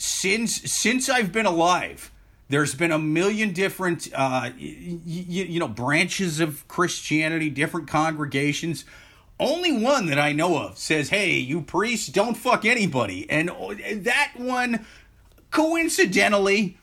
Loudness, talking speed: -23 LUFS, 130 wpm